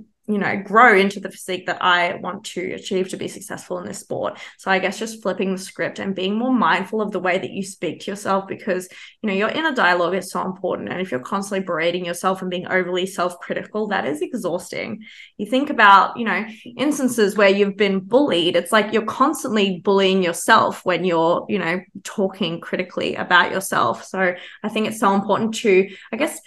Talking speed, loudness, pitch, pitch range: 210 wpm, -20 LUFS, 195 Hz, 185-215 Hz